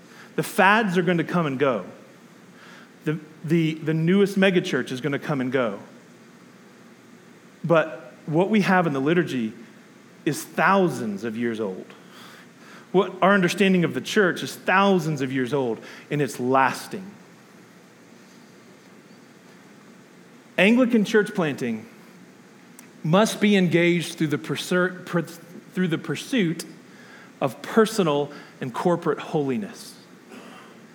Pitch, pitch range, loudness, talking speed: 180 Hz, 155-200 Hz, -23 LUFS, 120 wpm